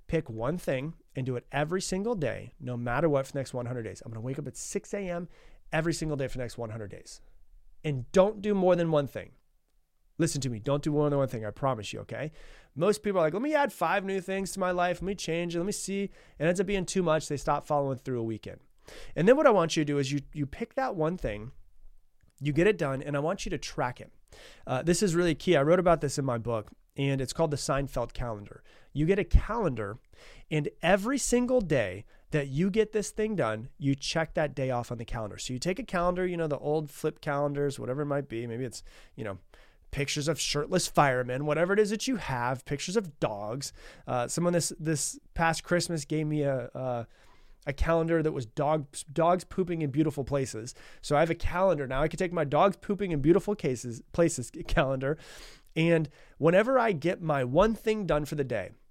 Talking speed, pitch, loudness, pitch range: 235 wpm, 150 Hz, -29 LUFS, 130-175 Hz